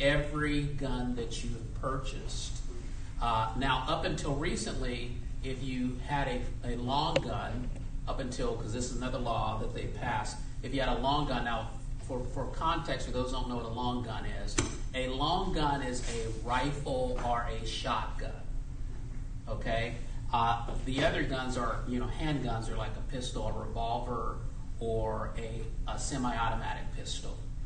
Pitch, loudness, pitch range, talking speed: 125 Hz, -35 LUFS, 115-130 Hz, 165 wpm